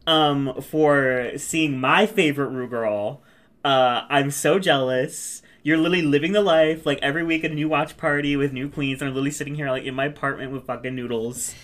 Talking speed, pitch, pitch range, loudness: 200 wpm, 140 Hz, 130-155 Hz, -22 LUFS